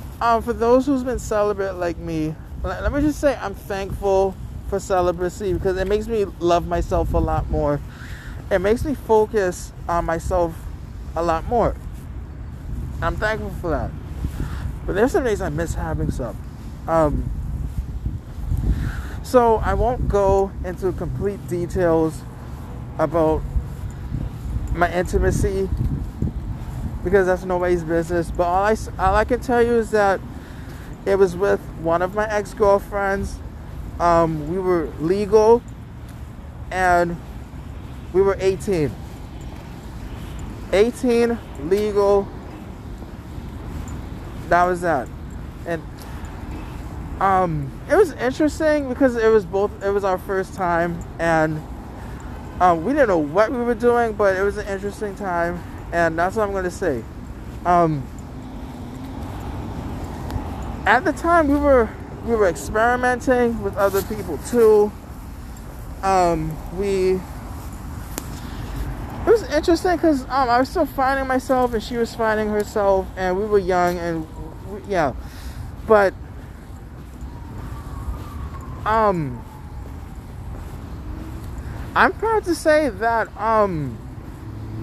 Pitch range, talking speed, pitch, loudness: 165-225 Hz, 120 wpm, 195 Hz, -21 LUFS